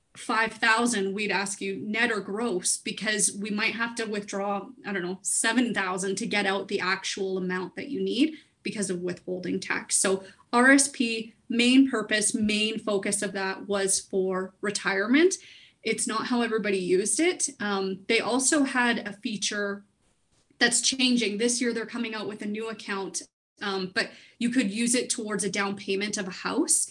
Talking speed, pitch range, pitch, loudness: 170 wpm, 195-235 Hz, 210 Hz, -26 LUFS